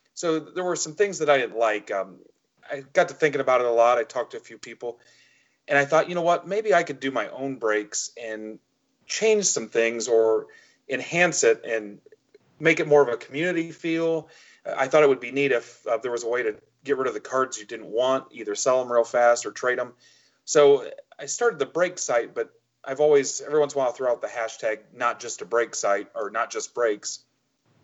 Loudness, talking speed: -24 LUFS, 235 wpm